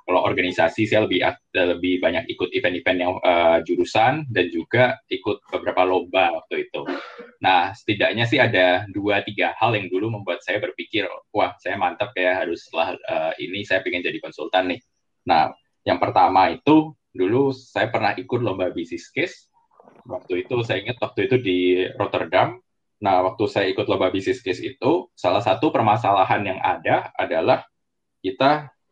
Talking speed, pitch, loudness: 160 wpm, 125 Hz, -21 LUFS